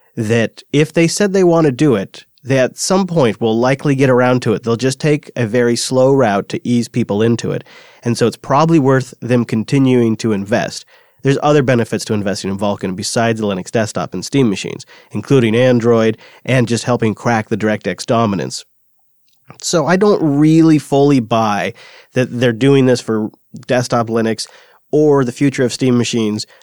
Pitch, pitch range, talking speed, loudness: 120 Hz, 110-140 Hz, 185 wpm, -15 LUFS